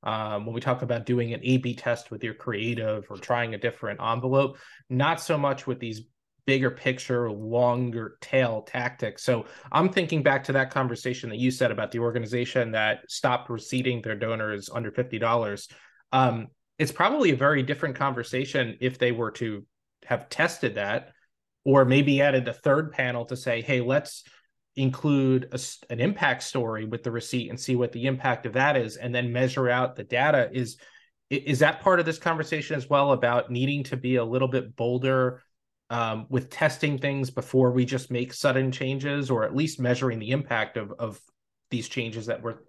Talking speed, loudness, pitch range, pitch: 185 wpm, -26 LUFS, 120-135 Hz, 125 Hz